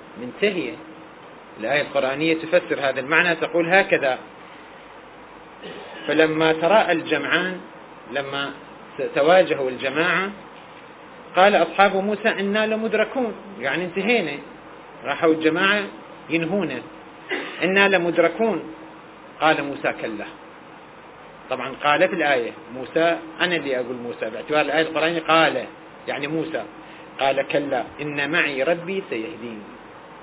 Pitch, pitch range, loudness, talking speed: 165 Hz, 145-190 Hz, -21 LUFS, 95 wpm